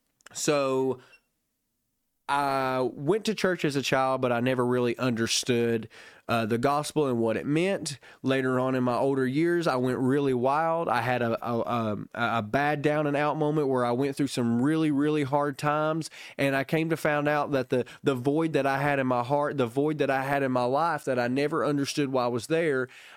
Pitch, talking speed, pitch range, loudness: 135 Hz, 210 wpm, 125-150 Hz, -27 LUFS